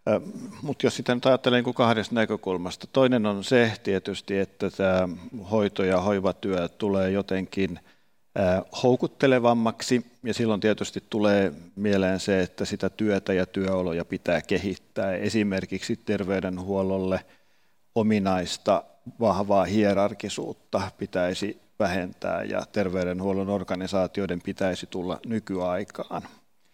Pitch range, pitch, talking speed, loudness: 95-110 Hz, 100 Hz, 105 wpm, -26 LUFS